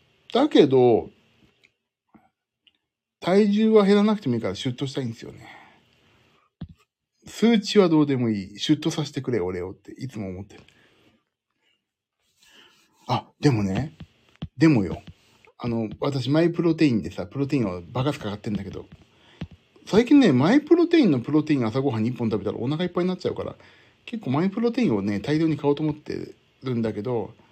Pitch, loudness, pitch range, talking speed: 140 Hz, -23 LUFS, 110-170 Hz, 345 characters per minute